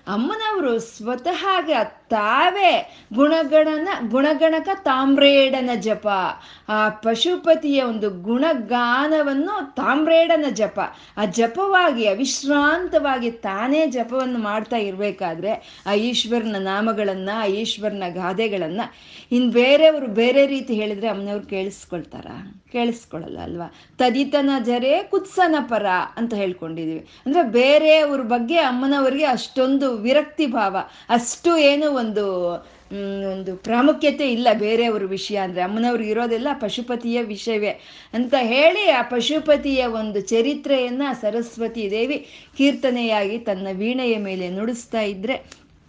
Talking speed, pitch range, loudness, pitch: 100 wpm, 215-290 Hz, -20 LUFS, 240 Hz